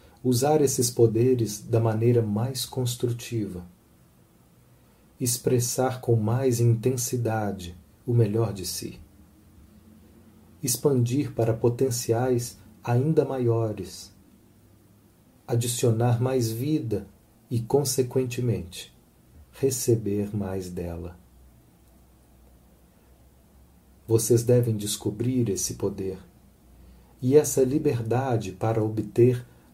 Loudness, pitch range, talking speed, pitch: -25 LUFS, 95-125 Hz, 75 wpm, 115 Hz